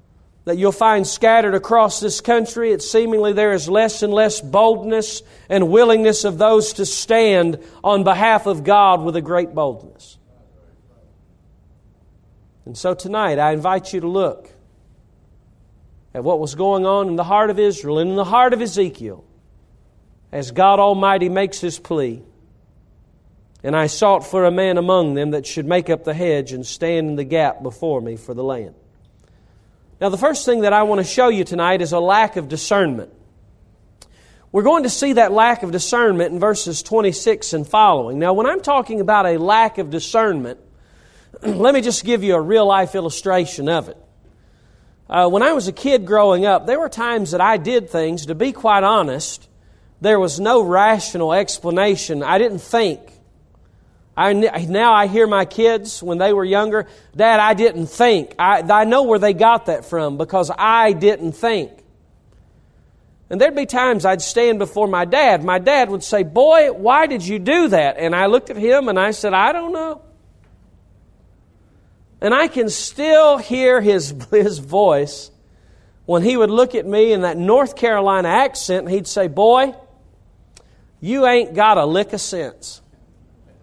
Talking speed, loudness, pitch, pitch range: 175 wpm, -16 LUFS, 195 Hz, 150-220 Hz